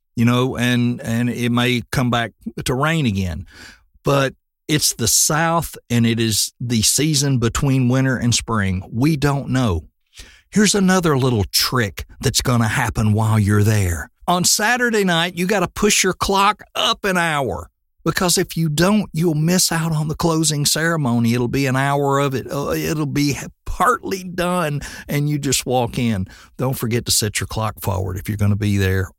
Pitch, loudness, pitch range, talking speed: 130 Hz, -18 LUFS, 115-165 Hz, 185 wpm